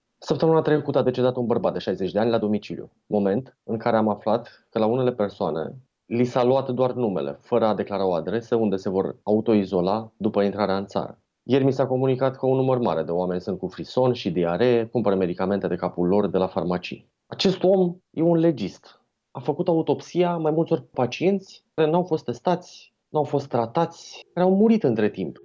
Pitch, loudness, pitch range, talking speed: 125 Hz, -23 LUFS, 100-150 Hz, 205 wpm